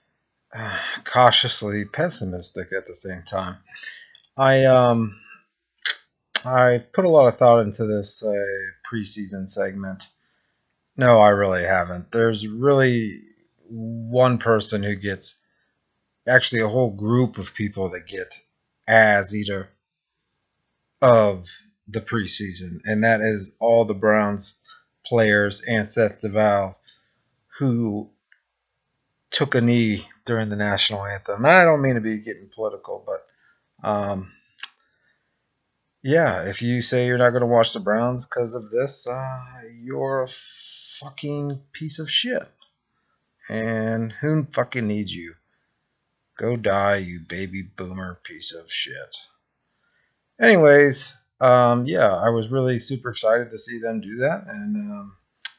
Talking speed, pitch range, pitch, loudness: 130 wpm, 100-125 Hz, 115 Hz, -20 LUFS